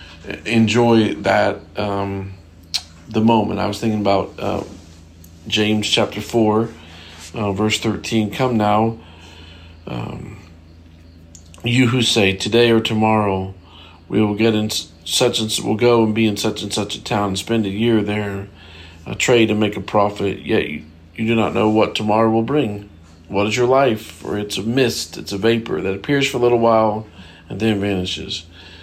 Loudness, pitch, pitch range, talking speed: -18 LUFS, 105 Hz, 85-110 Hz, 170 wpm